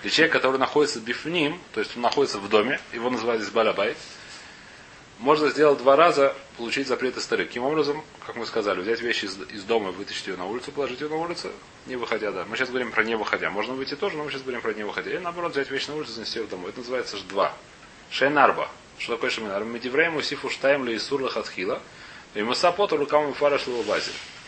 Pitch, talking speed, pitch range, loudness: 140 Hz, 220 wpm, 125-150 Hz, -25 LUFS